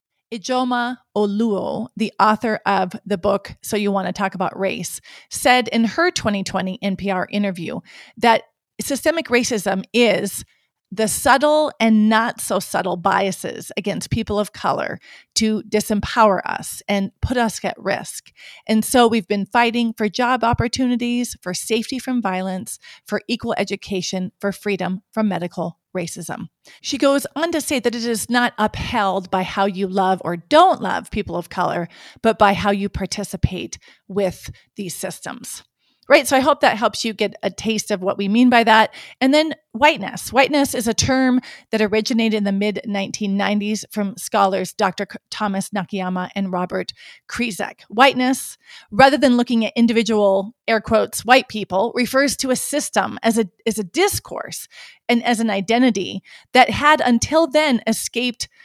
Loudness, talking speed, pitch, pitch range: -19 LUFS, 160 wpm, 220 Hz, 195-245 Hz